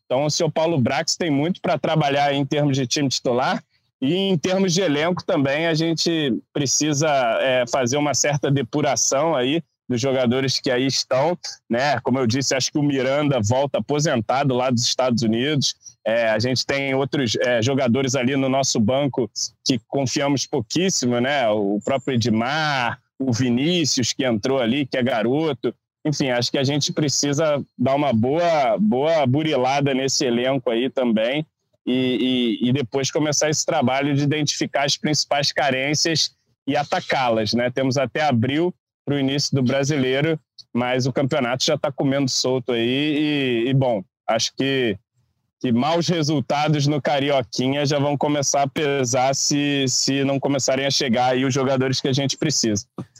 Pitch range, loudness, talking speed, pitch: 125-150 Hz, -20 LUFS, 165 wpm, 135 Hz